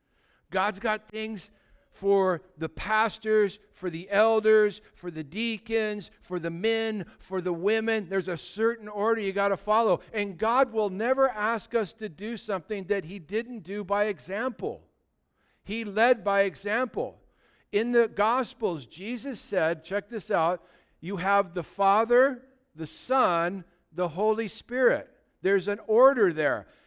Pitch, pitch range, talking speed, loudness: 210 Hz, 195-225 Hz, 145 wpm, -27 LUFS